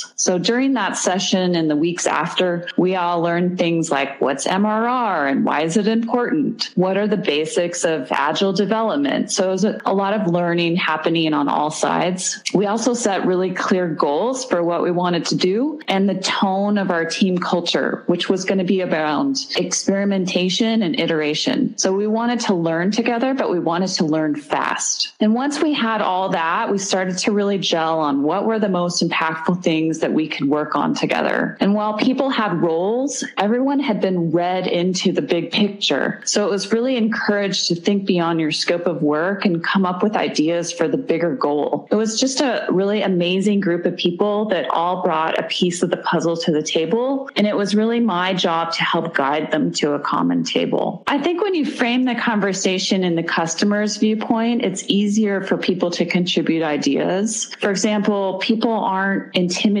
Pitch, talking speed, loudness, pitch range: 190 Hz, 195 wpm, -19 LUFS, 170-220 Hz